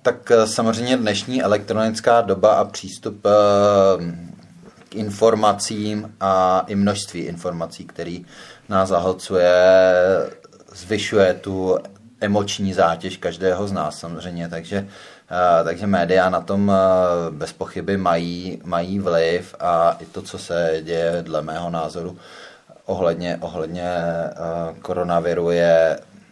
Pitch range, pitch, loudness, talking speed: 85-100 Hz, 95 Hz, -19 LUFS, 105 wpm